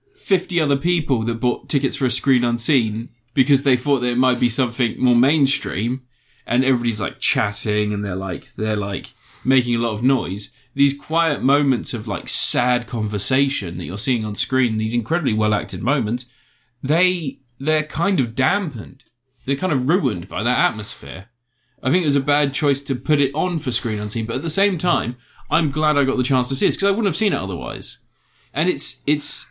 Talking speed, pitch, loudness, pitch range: 205 wpm, 130 Hz, -18 LUFS, 115-140 Hz